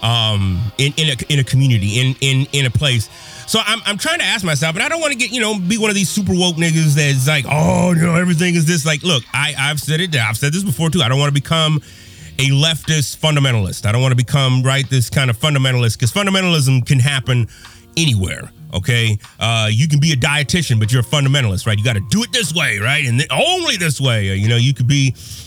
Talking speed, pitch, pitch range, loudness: 250 wpm, 140 Hz, 125-165 Hz, -15 LUFS